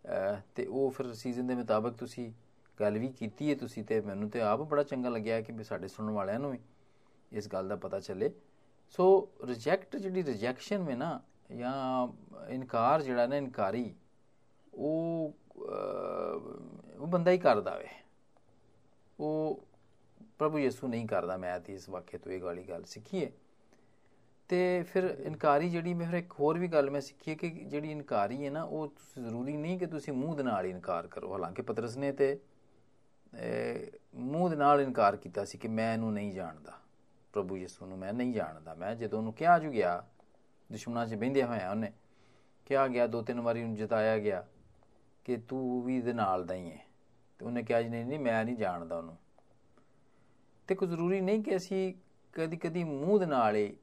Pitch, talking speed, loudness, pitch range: 130 Hz, 175 wpm, -34 LUFS, 110-155 Hz